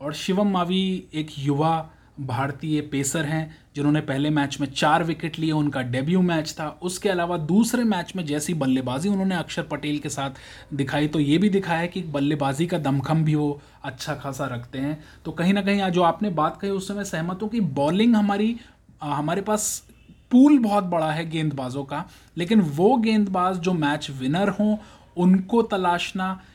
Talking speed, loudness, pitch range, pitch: 180 wpm, -23 LUFS, 145-190 Hz, 160 Hz